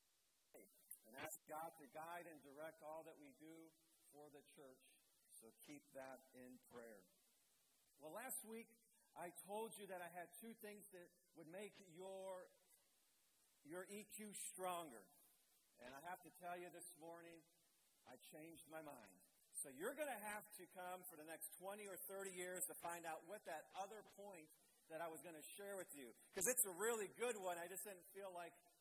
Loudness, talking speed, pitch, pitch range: -53 LUFS, 185 wpm, 175 Hz, 160-195 Hz